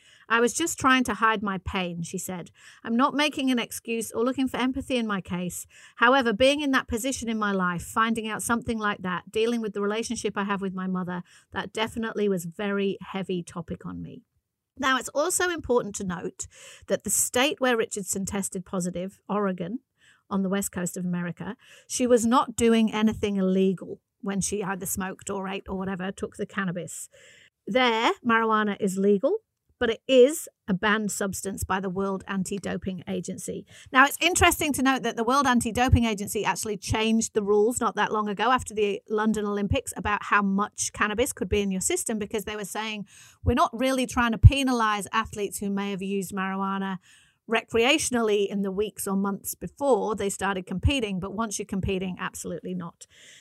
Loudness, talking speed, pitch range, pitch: -26 LUFS, 190 wpm, 195-235 Hz, 210 Hz